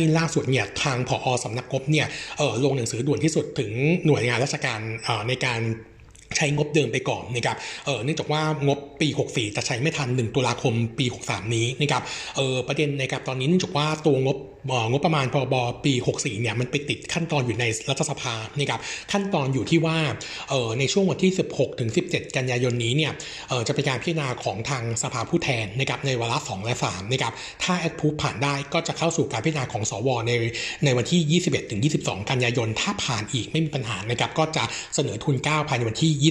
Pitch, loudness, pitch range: 135 Hz, -24 LUFS, 120-150 Hz